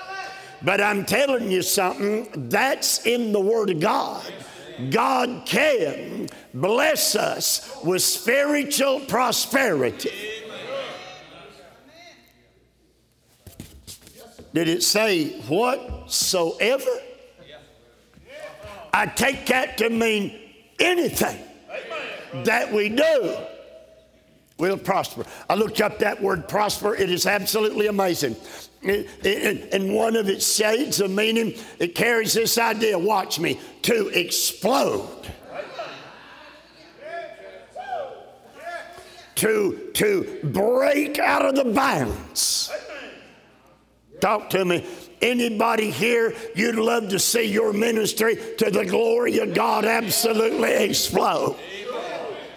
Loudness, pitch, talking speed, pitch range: -22 LUFS, 225 Hz, 95 wpm, 205-305 Hz